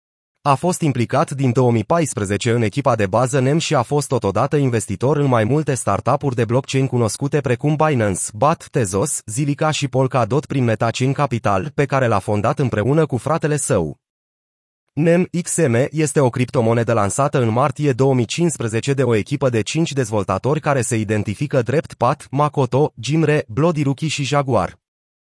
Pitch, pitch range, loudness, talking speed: 135 Hz, 115-150 Hz, -18 LUFS, 155 wpm